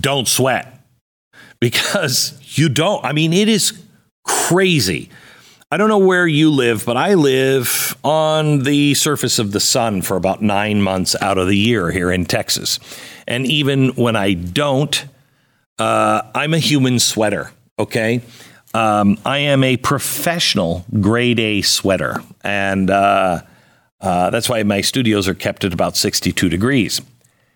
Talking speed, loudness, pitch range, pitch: 150 wpm, -16 LUFS, 105-145 Hz, 125 Hz